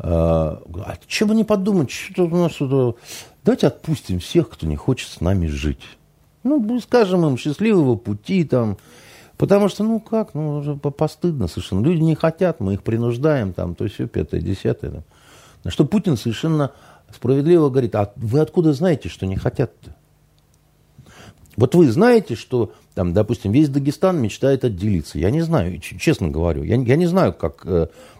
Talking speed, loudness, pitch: 160 wpm, -19 LUFS, 130 Hz